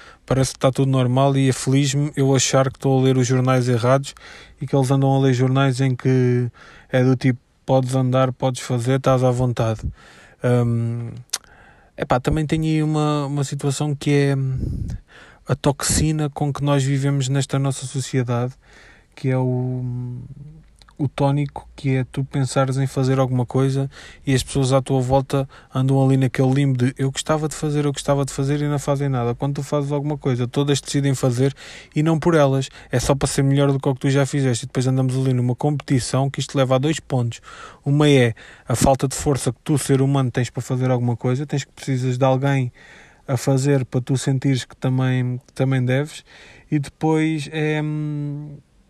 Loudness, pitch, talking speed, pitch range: -20 LUFS, 135 Hz, 200 wpm, 130-140 Hz